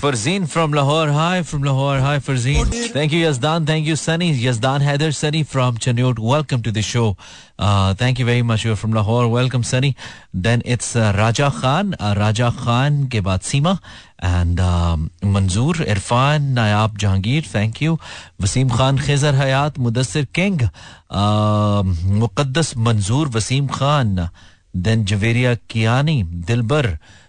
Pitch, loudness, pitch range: 120 Hz, -18 LUFS, 105-145 Hz